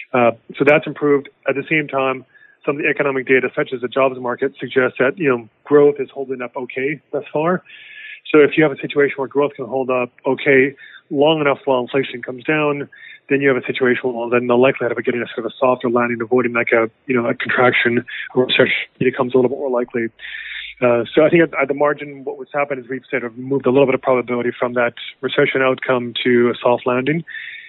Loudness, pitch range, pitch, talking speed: -18 LUFS, 125-145 Hz, 130 Hz, 240 wpm